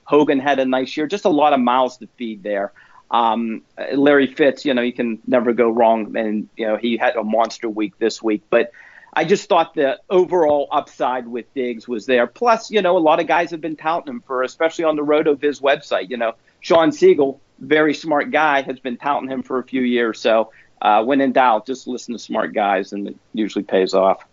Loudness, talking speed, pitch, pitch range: -18 LUFS, 225 wpm, 130 Hz, 115-150 Hz